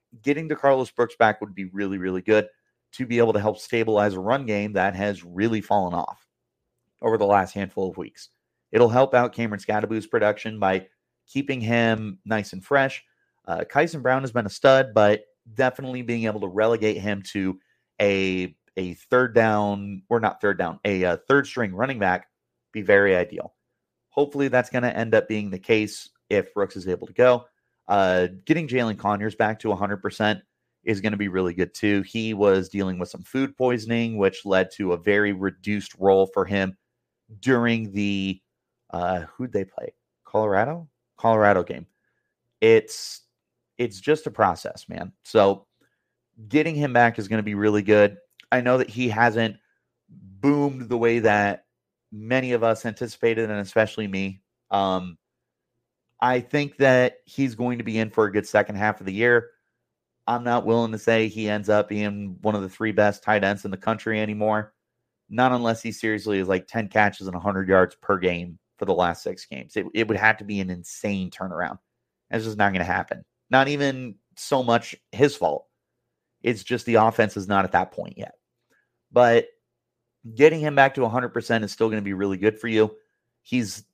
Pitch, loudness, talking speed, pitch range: 110 Hz, -23 LUFS, 190 wpm, 100-120 Hz